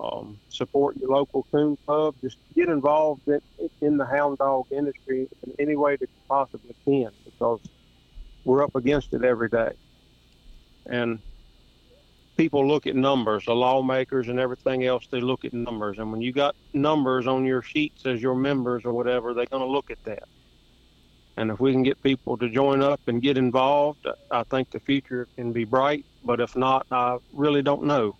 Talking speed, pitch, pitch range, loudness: 185 wpm, 130 Hz, 125-140 Hz, -25 LUFS